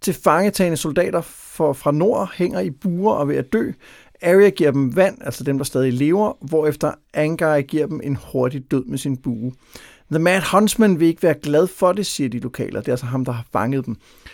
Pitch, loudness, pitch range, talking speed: 150 Hz, -19 LUFS, 135-180 Hz, 215 wpm